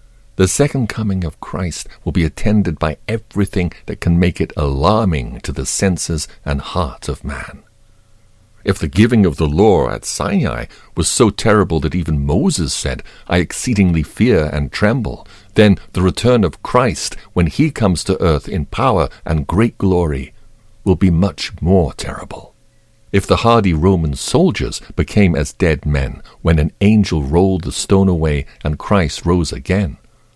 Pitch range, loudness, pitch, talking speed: 80-105 Hz, -16 LUFS, 95 Hz, 160 wpm